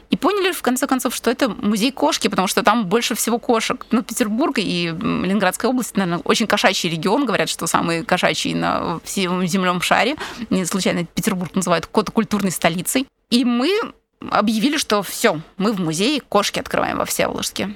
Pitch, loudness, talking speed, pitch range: 215 Hz, -19 LUFS, 180 wpm, 185-245 Hz